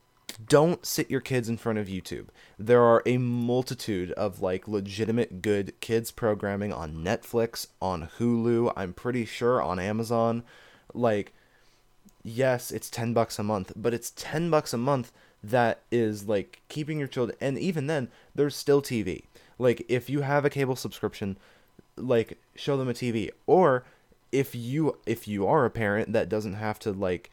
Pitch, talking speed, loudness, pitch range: 115 Hz, 170 wpm, -28 LUFS, 105-125 Hz